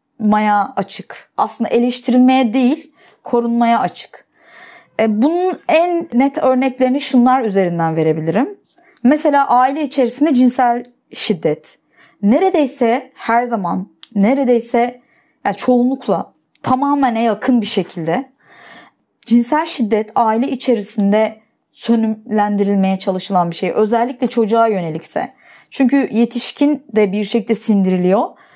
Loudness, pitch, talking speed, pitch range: -16 LUFS, 235 Hz, 95 wpm, 210-260 Hz